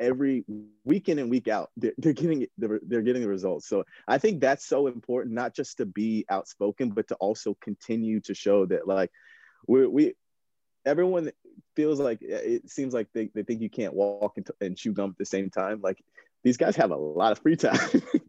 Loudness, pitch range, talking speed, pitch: -27 LUFS, 105-160 Hz, 205 wpm, 120 Hz